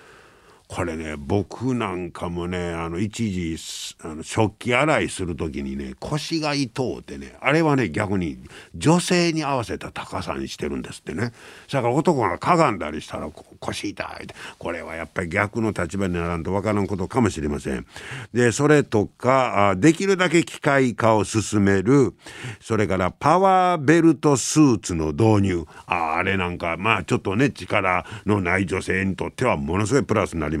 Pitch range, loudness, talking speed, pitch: 90-130 Hz, -22 LUFS, 330 characters per minute, 100 Hz